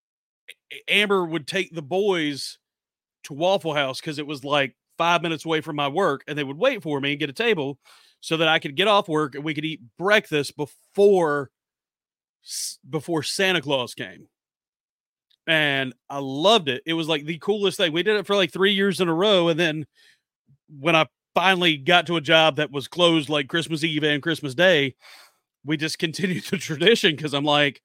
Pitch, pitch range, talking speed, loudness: 160 Hz, 145-180 Hz, 195 wpm, -22 LUFS